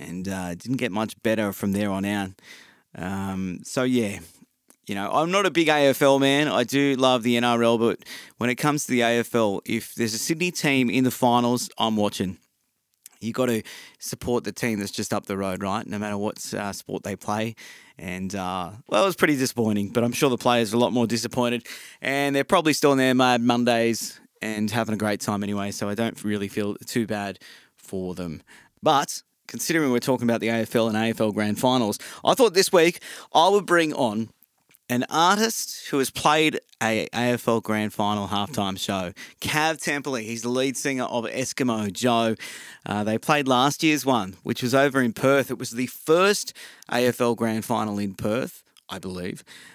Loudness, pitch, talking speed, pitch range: -23 LUFS, 115 Hz, 195 wpm, 105-130 Hz